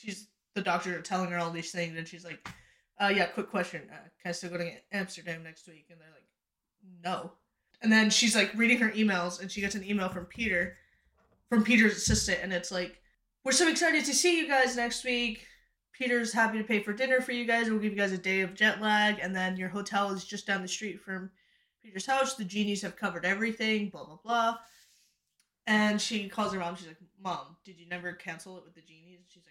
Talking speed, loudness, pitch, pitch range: 230 wpm, -29 LUFS, 200 Hz, 175-220 Hz